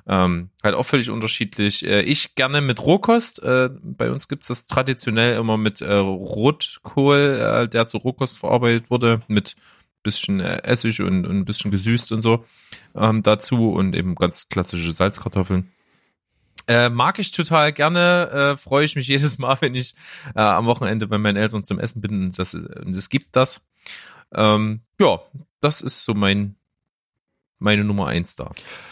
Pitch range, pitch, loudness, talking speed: 105-135 Hz, 115 Hz, -19 LUFS, 165 wpm